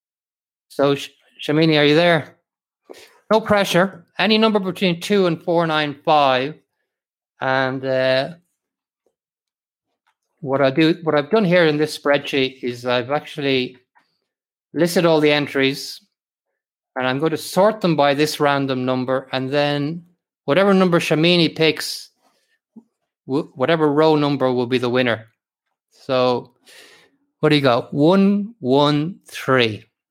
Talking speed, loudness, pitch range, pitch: 130 wpm, -18 LUFS, 135-175 Hz, 150 Hz